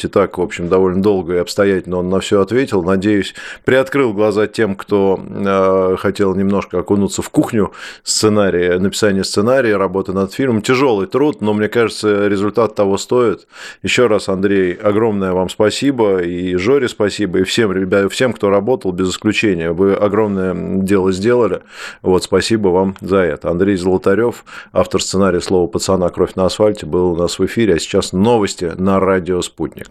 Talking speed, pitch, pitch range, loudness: 165 wpm, 95 Hz, 95-105 Hz, -15 LUFS